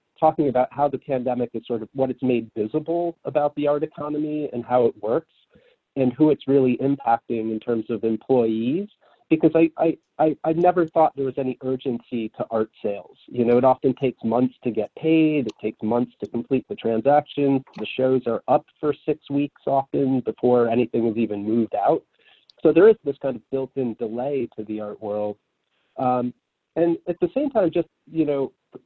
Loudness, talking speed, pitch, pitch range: -23 LUFS, 195 wpm, 130 Hz, 120-150 Hz